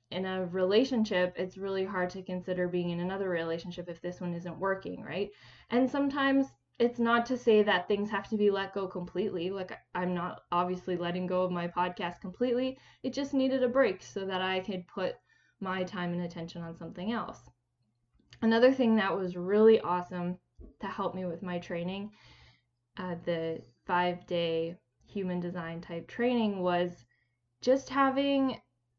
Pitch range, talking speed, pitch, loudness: 175-210 Hz, 170 wpm, 185 Hz, -31 LUFS